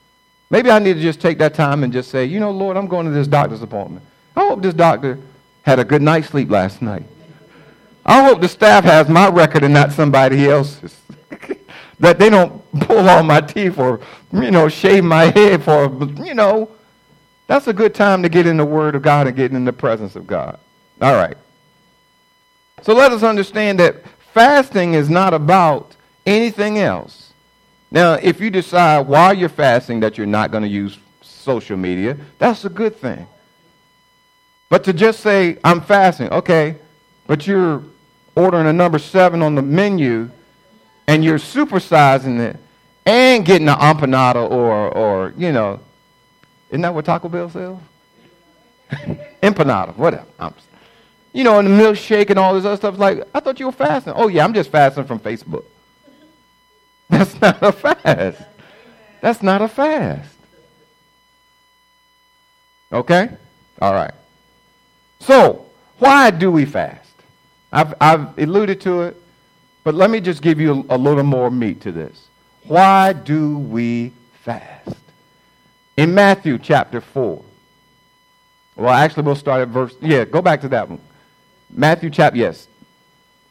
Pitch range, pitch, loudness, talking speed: 145-200 Hz, 165 Hz, -14 LUFS, 160 wpm